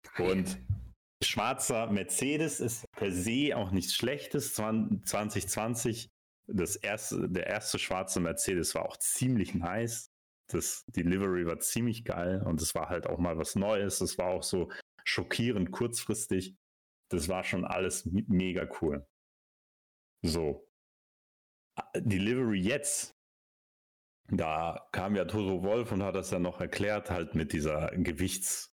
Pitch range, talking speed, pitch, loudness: 90-115 Hz, 130 wpm, 95 Hz, -32 LUFS